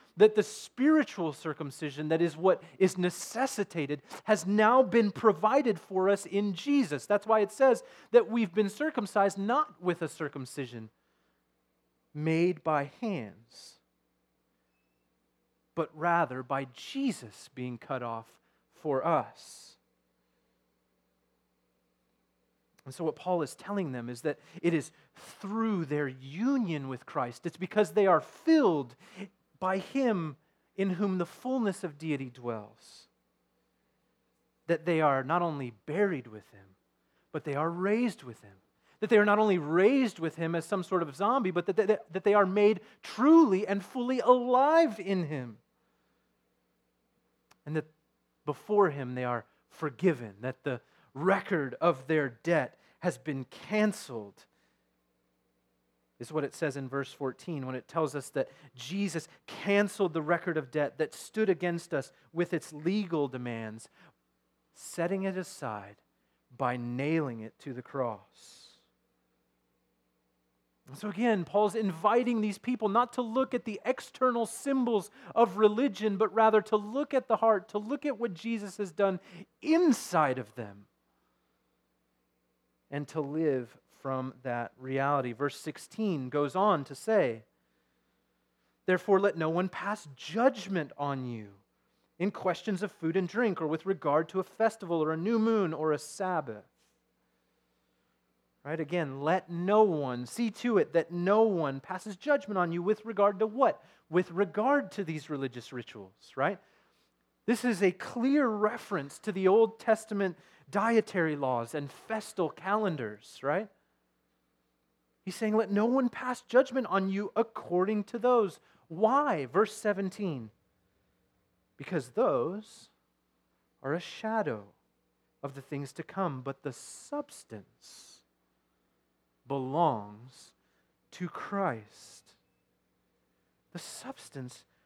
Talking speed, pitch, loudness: 135 wpm, 160 Hz, -30 LUFS